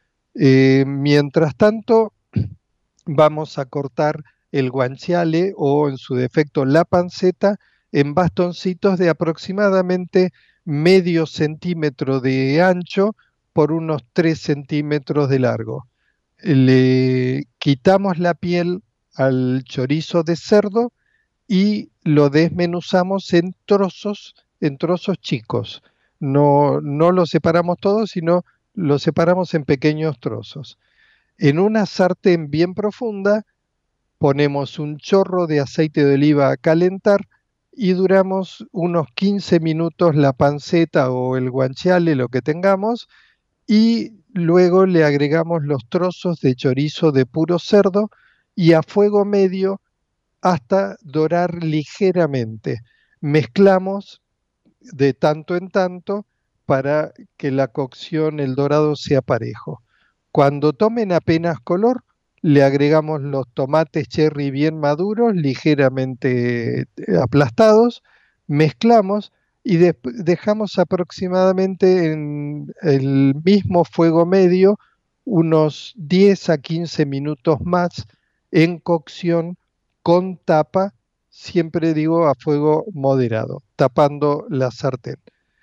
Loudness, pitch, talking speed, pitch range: -18 LUFS, 165 Hz, 105 wpm, 145-185 Hz